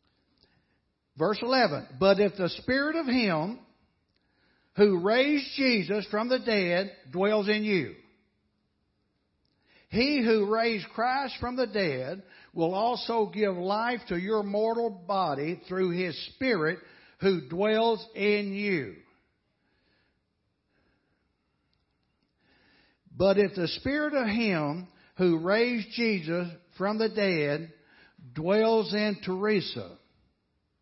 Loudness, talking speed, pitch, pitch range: -27 LUFS, 105 wpm, 205 Hz, 180-225 Hz